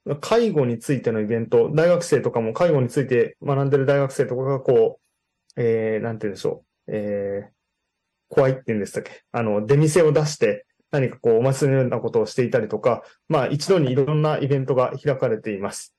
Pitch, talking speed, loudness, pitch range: 135 Hz, 400 characters per minute, -21 LUFS, 115-155 Hz